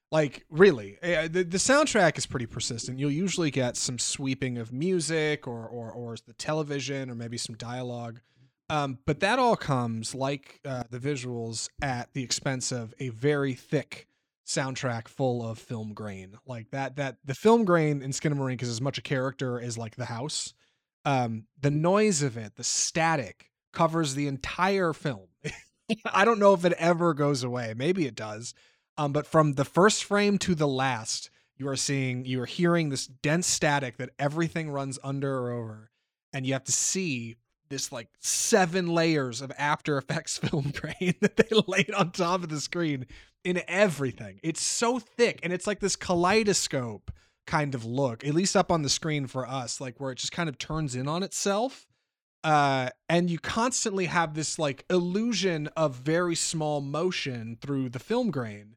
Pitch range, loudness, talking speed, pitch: 125-170 Hz, -28 LUFS, 180 wpm, 140 Hz